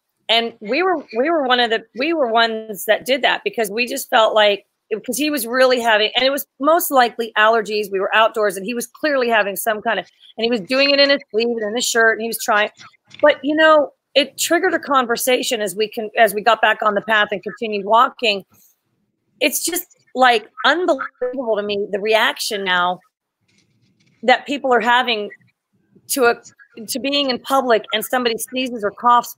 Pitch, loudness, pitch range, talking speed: 235 Hz, -17 LUFS, 215-265 Hz, 205 wpm